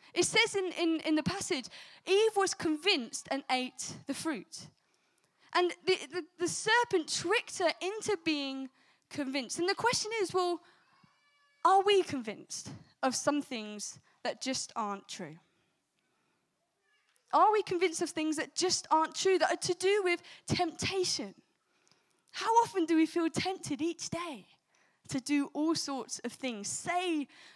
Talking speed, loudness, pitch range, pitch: 150 wpm, -32 LUFS, 285-370 Hz, 335 Hz